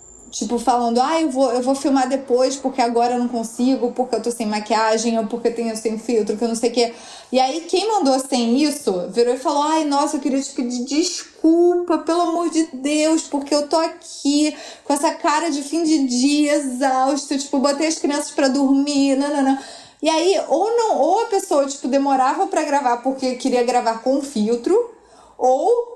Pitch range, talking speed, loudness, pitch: 245-315 Hz, 210 wpm, -19 LUFS, 275 Hz